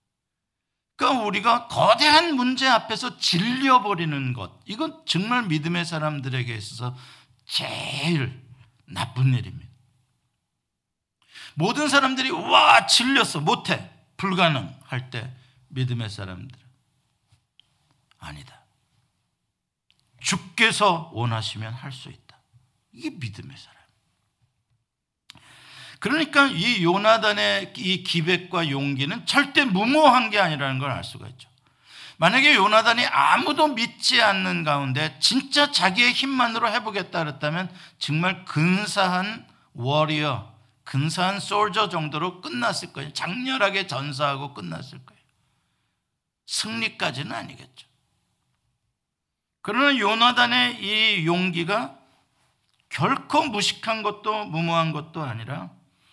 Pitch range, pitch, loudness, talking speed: 130-220 Hz, 170 Hz, -21 LUFS, 240 characters per minute